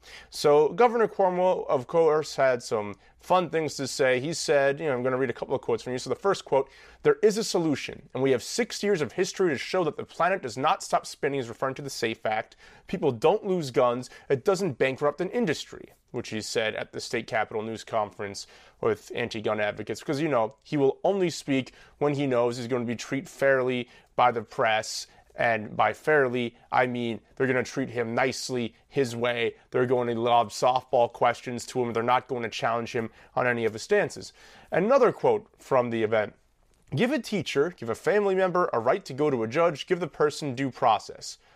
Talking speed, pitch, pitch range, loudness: 220 wpm, 135 Hz, 120-170 Hz, -27 LUFS